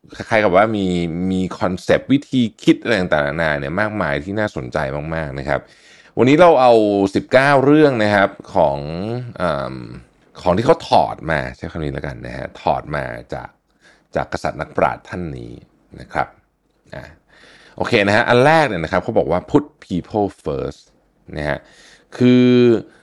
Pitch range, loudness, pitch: 75-120 Hz, -17 LUFS, 100 Hz